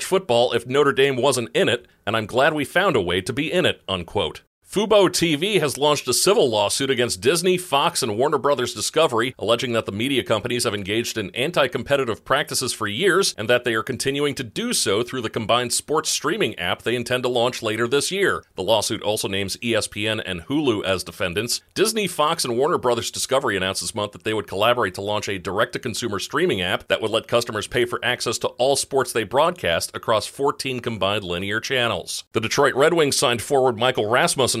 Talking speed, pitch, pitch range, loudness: 210 wpm, 120 Hz, 110-145 Hz, -21 LUFS